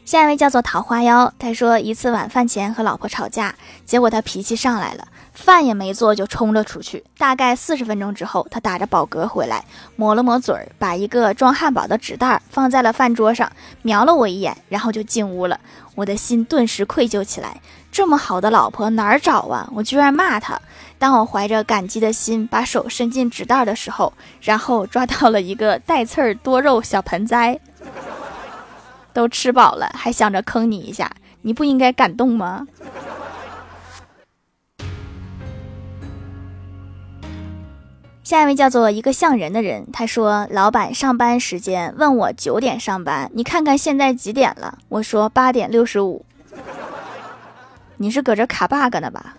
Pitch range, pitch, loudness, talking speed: 200-250 Hz, 230 Hz, -17 LUFS, 250 characters per minute